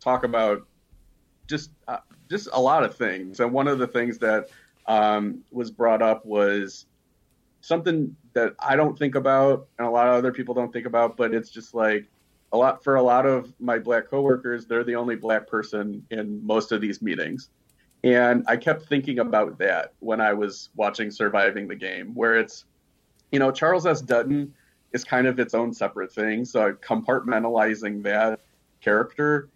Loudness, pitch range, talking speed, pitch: -23 LUFS, 110-135 Hz, 180 wpm, 120 Hz